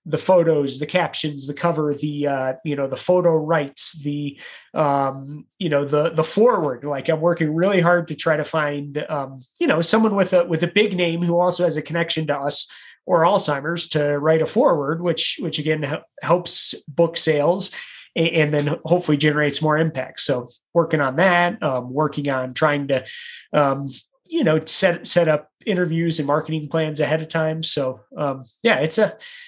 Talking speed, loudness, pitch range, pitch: 190 wpm, -20 LUFS, 145-170 Hz, 155 Hz